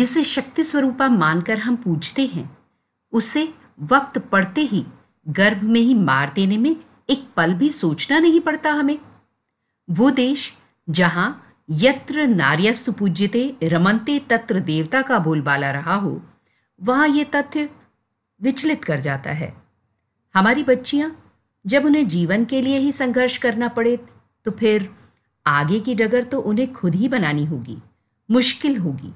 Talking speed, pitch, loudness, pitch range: 140 wpm, 230 Hz, -19 LUFS, 170-270 Hz